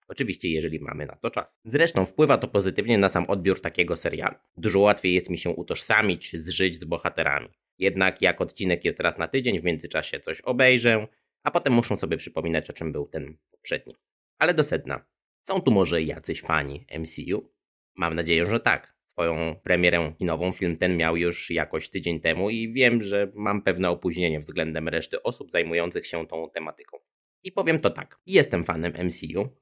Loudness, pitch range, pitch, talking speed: -25 LUFS, 80-100 Hz, 85 Hz, 180 wpm